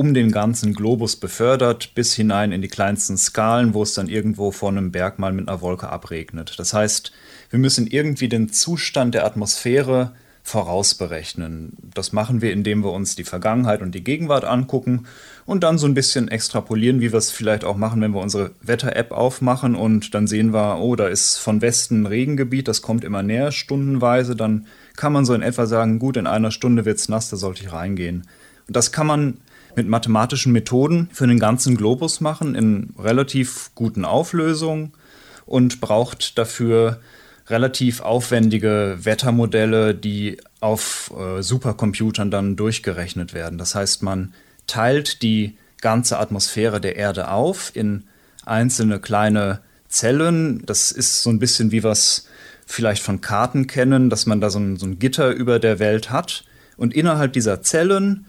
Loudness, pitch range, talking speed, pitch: -19 LUFS, 105-125 Hz, 170 wpm, 110 Hz